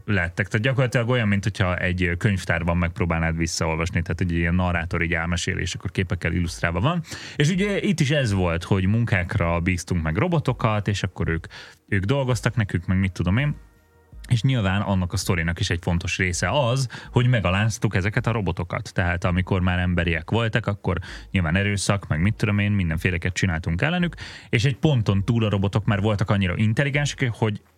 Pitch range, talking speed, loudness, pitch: 90-115 Hz, 175 wpm, -23 LUFS, 100 Hz